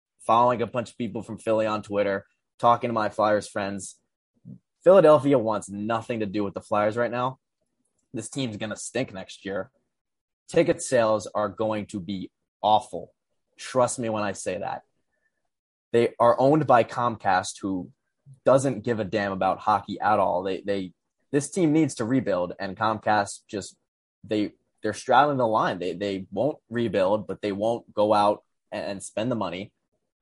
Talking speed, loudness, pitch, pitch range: 170 wpm, -25 LUFS, 110 Hz, 100-120 Hz